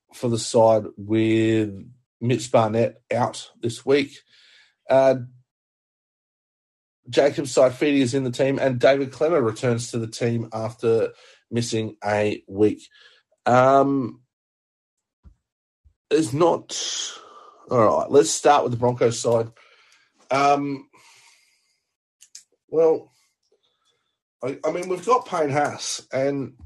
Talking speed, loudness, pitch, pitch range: 110 wpm, -22 LUFS, 130 Hz, 115-155 Hz